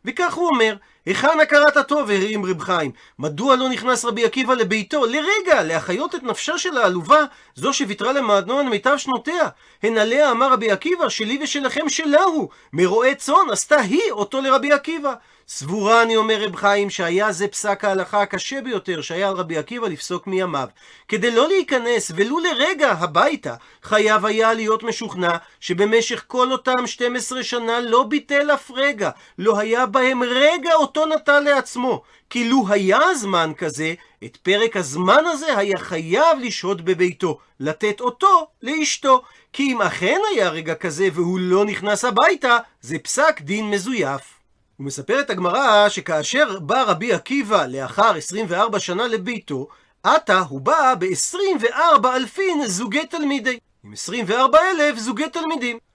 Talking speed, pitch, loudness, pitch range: 150 wpm, 240 Hz, -19 LUFS, 200-290 Hz